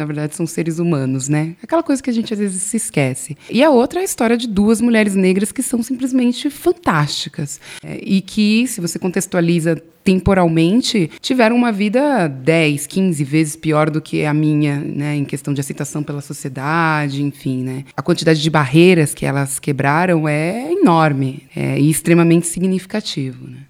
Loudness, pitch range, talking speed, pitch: -16 LUFS, 150-215 Hz, 175 wpm, 165 Hz